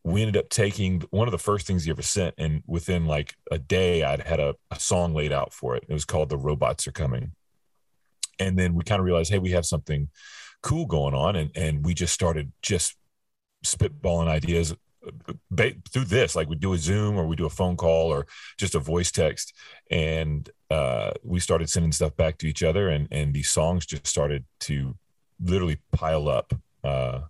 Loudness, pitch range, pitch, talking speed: -26 LUFS, 75-90 Hz, 80 Hz, 205 wpm